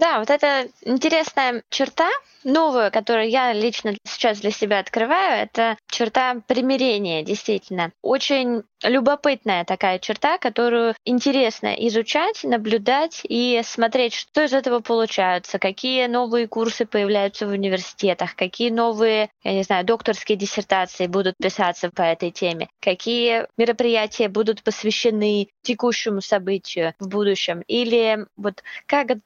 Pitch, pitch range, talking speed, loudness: 225 Hz, 200-245 Hz, 125 wpm, -21 LUFS